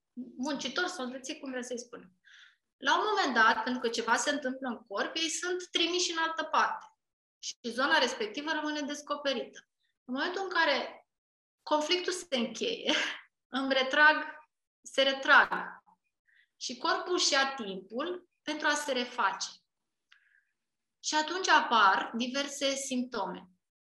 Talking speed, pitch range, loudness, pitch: 130 wpm, 250-330 Hz, -30 LUFS, 290 Hz